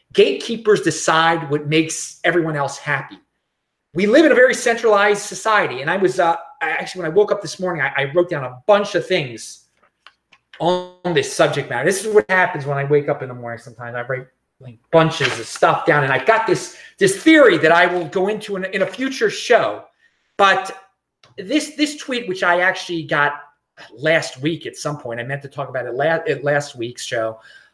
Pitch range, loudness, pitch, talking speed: 145-205 Hz, -18 LUFS, 170 Hz, 210 wpm